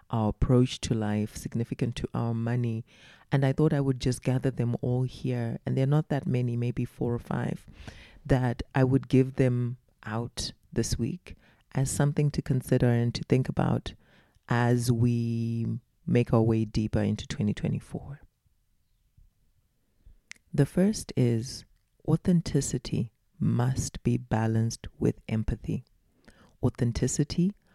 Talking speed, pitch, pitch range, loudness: 130 wpm, 125 Hz, 115-135 Hz, -28 LUFS